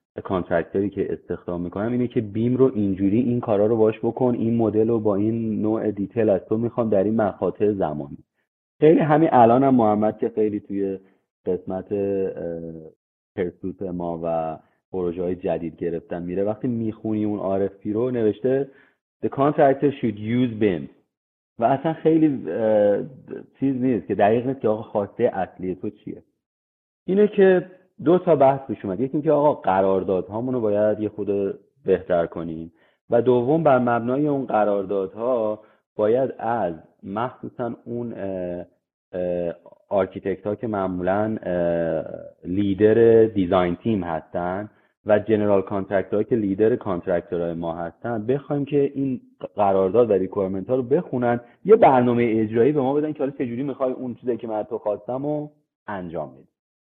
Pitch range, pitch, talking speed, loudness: 95-125 Hz, 110 Hz, 150 wpm, -22 LUFS